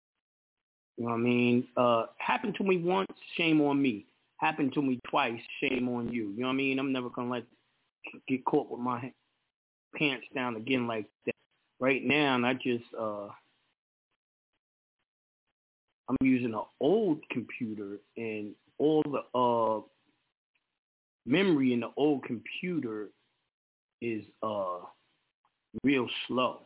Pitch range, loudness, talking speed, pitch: 115-135 Hz, -31 LUFS, 135 wpm, 125 Hz